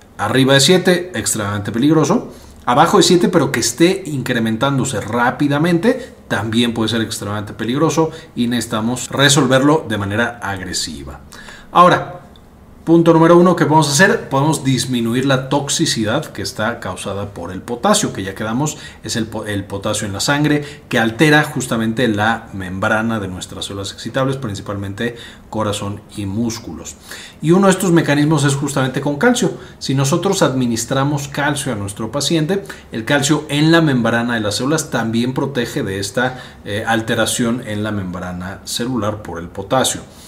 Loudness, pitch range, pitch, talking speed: -16 LUFS, 105-145 Hz, 120 Hz, 150 wpm